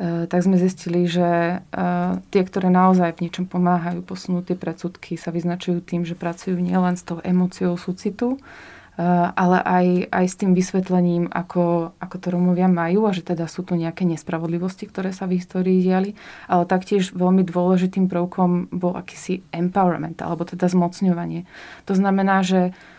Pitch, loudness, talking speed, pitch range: 180 Hz, -21 LUFS, 155 wpm, 175-185 Hz